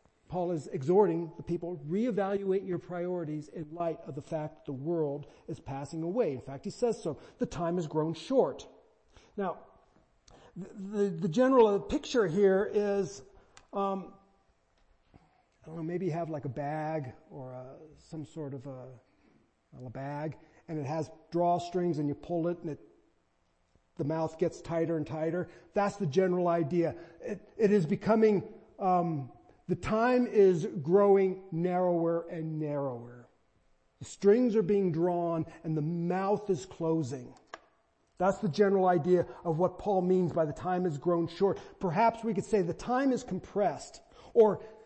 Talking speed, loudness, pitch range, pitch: 160 wpm, -31 LUFS, 155-195 Hz, 170 Hz